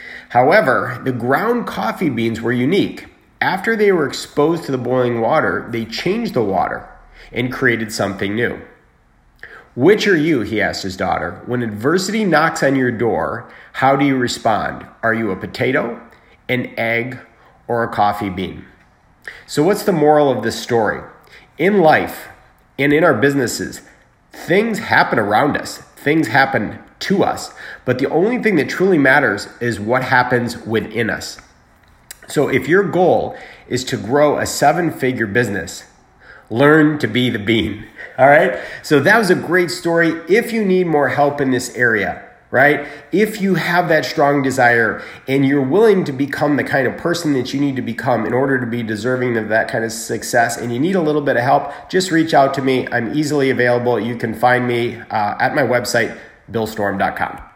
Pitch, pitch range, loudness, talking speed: 130 Hz, 115-150 Hz, -16 LUFS, 180 wpm